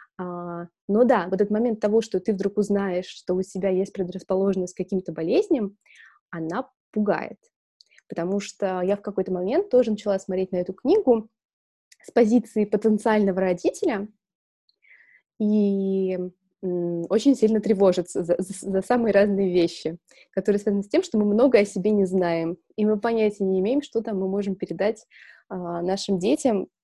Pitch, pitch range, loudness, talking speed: 195 Hz, 185-215 Hz, -24 LUFS, 155 wpm